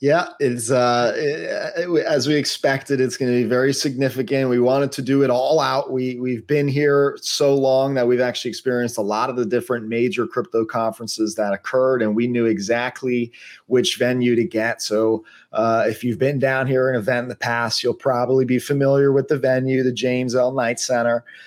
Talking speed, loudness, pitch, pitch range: 200 wpm, -20 LUFS, 125 Hz, 120-135 Hz